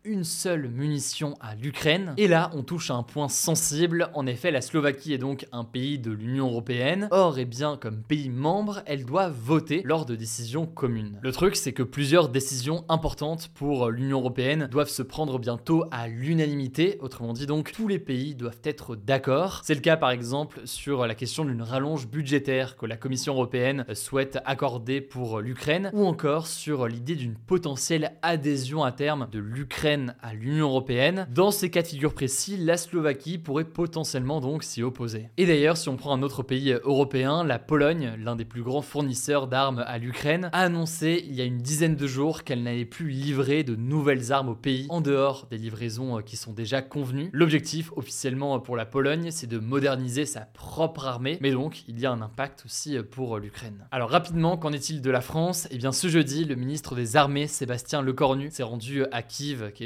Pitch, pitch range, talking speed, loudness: 140 Hz, 125-155 Hz, 200 wpm, -27 LUFS